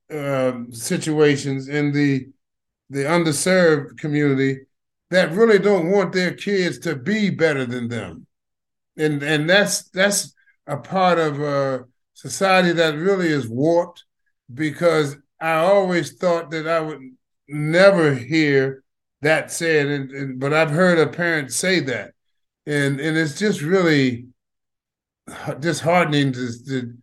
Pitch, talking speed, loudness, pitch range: 155 Hz, 135 wpm, -19 LUFS, 135-175 Hz